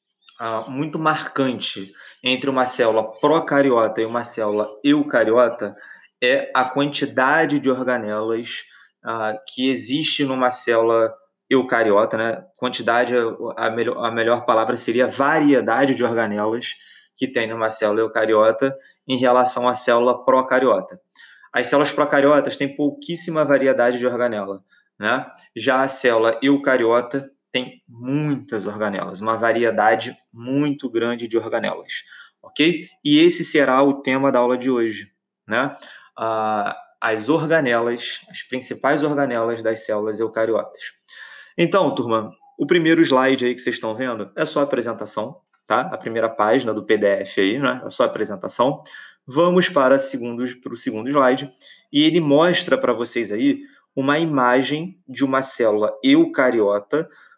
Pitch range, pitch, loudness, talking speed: 115-145 Hz, 130 Hz, -19 LUFS, 135 wpm